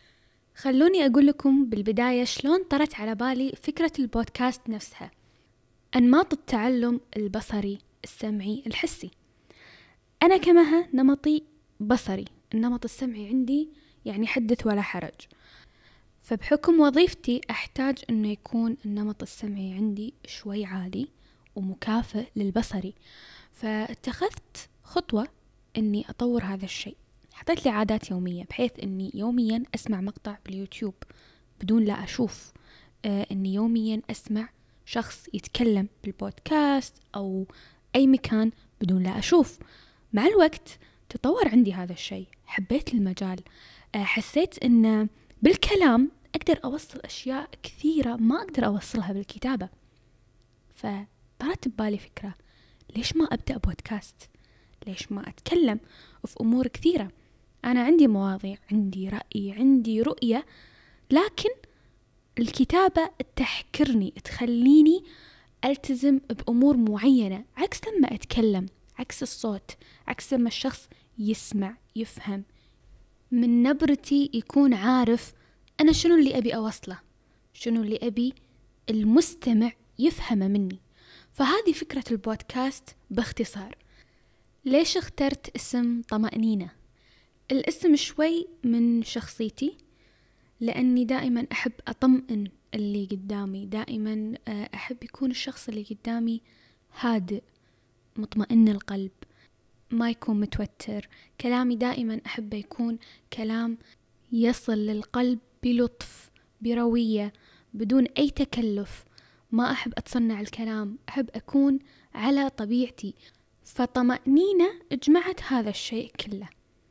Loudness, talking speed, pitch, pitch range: -26 LUFS, 100 wpm, 230 Hz, 205-265 Hz